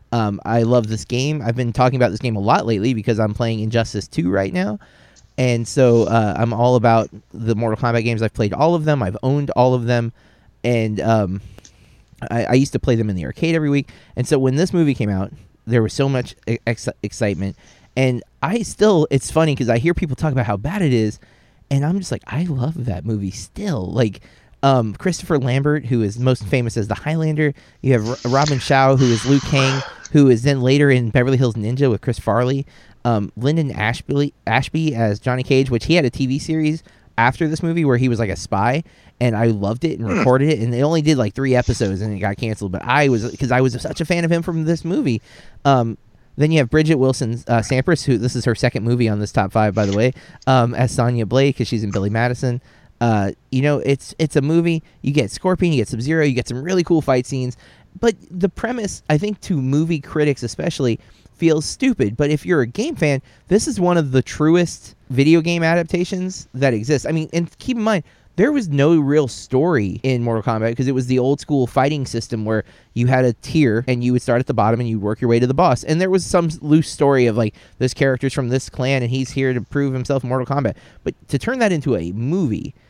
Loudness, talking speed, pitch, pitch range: -18 LUFS, 235 wpm, 130 Hz, 115-150 Hz